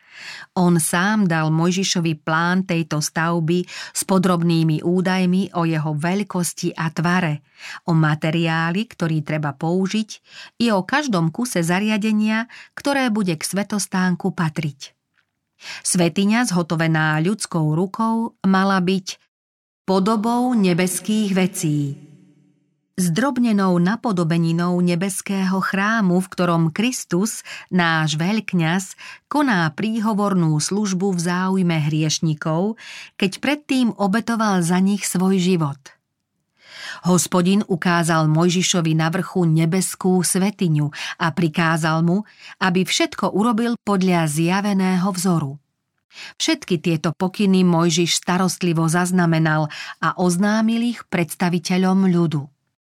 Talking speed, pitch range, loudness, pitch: 100 wpm, 165-200 Hz, -19 LUFS, 180 Hz